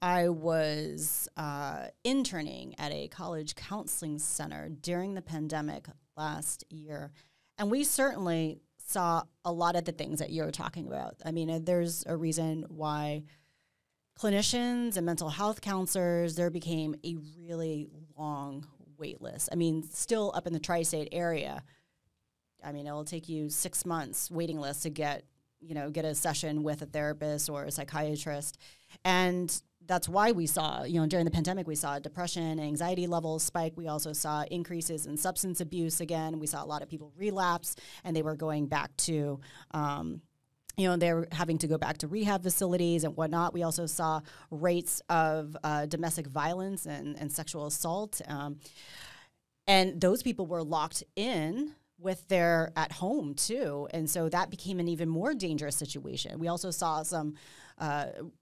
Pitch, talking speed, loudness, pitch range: 160 Hz, 170 wpm, -32 LUFS, 150-175 Hz